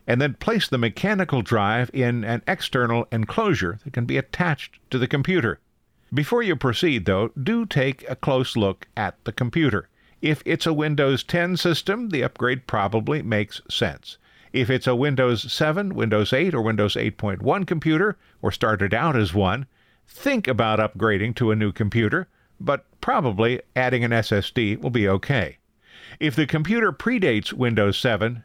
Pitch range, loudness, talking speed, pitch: 110-150 Hz, -23 LUFS, 160 wpm, 125 Hz